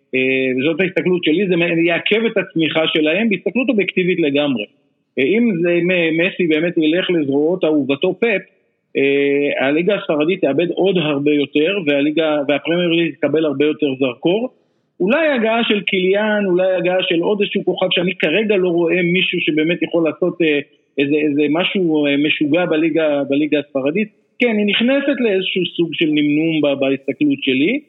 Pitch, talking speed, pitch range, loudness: 170 Hz, 140 wpm, 150-190 Hz, -16 LUFS